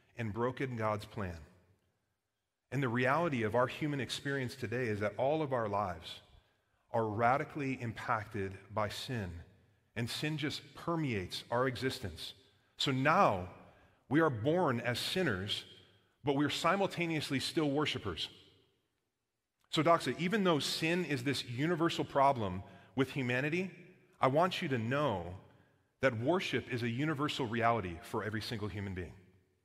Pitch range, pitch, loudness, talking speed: 105-145 Hz, 125 Hz, -34 LUFS, 140 wpm